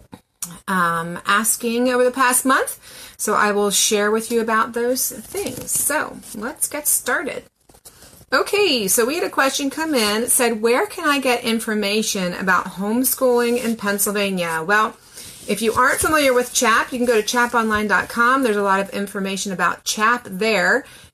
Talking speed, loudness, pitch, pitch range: 165 wpm, -18 LUFS, 230 Hz, 205-250 Hz